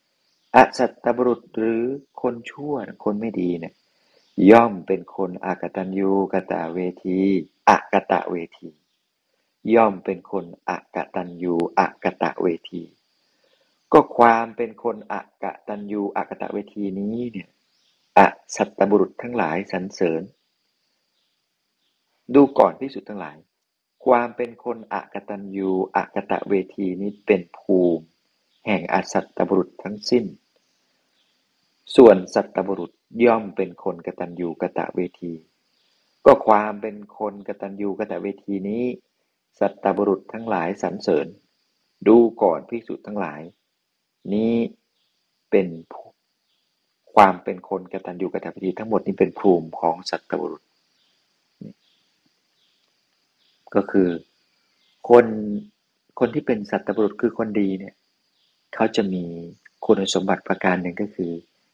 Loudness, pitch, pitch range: -21 LUFS, 100 Hz, 90-115 Hz